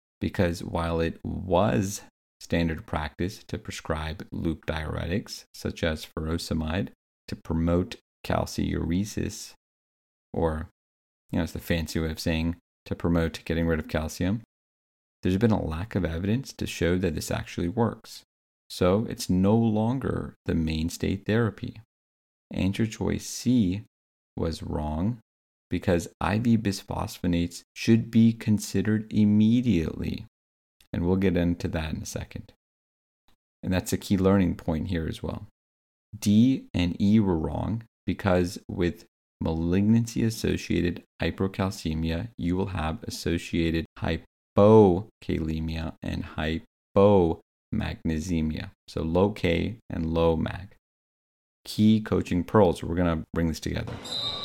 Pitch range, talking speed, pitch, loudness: 80-105 Hz, 120 wpm, 90 Hz, -27 LUFS